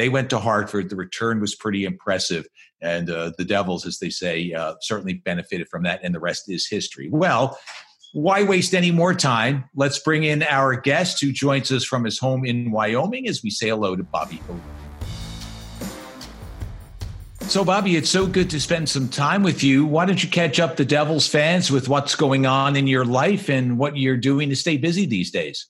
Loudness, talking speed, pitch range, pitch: -21 LUFS, 200 wpm, 105-160 Hz, 135 Hz